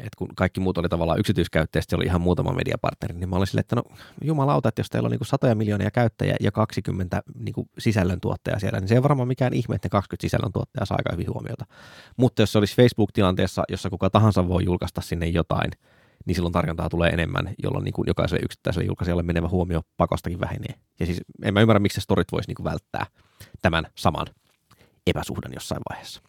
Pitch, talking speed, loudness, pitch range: 100 Hz, 205 wpm, -24 LUFS, 90-115 Hz